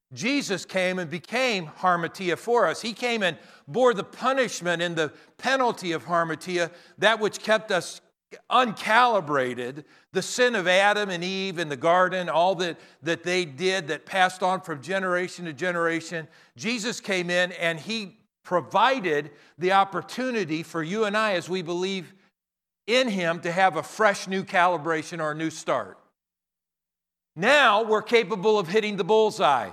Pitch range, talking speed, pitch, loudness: 170-215 Hz, 155 wpm, 185 Hz, -24 LUFS